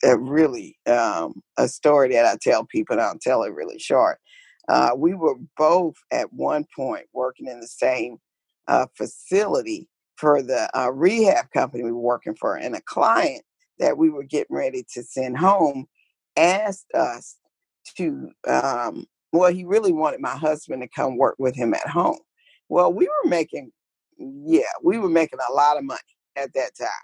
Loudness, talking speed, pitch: -22 LUFS, 180 wpm, 210 Hz